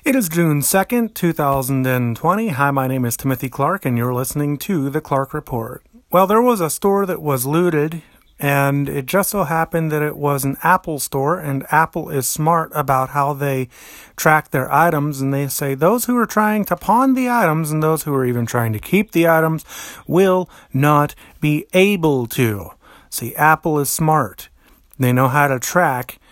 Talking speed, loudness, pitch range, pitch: 185 wpm, -18 LUFS, 135-170 Hz, 150 Hz